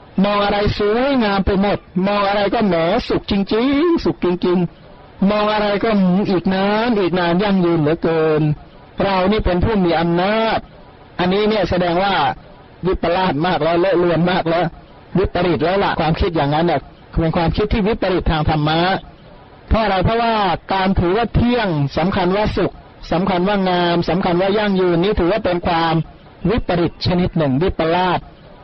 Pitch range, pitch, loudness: 170-205 Hz, 185 Hz, -17 LUFS